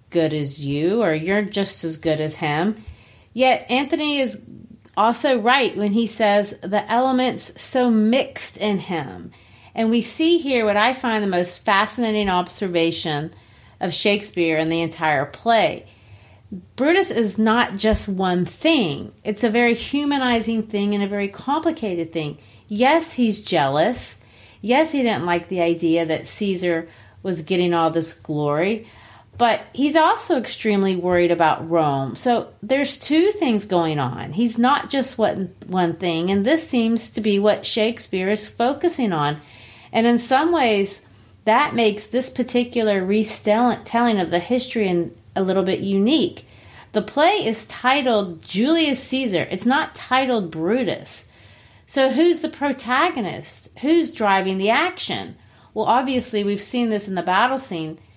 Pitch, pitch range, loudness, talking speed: 210 Hz, 175-245 Hz, -20 LUFS, 150 wpm